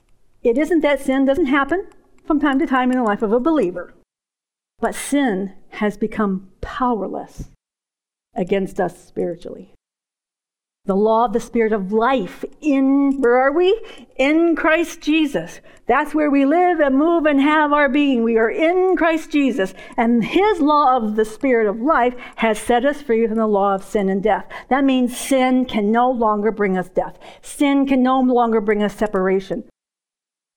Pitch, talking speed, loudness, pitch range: 255 Hz, 175 wpm, -18 LUFS, 220-295 Hz